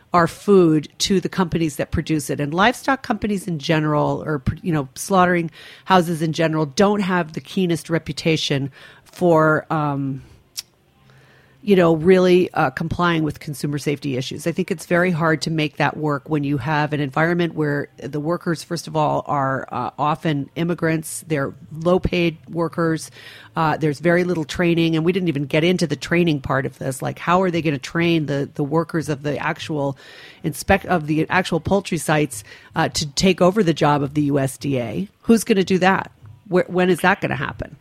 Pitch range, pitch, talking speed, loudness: 145-175 Hz, 160 Hz, 190 wpm, -20 LUFS